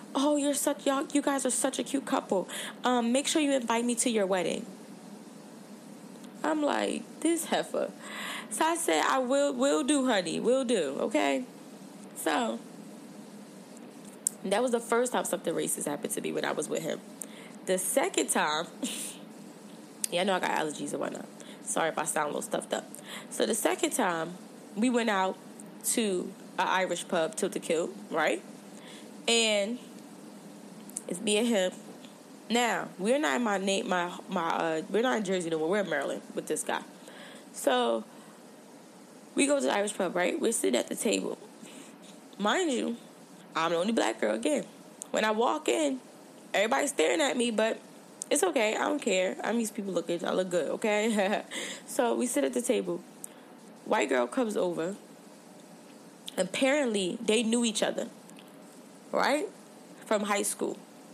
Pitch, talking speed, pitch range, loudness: 235 Hz, 170 wpm, 200-265 Hz, -29 LUFS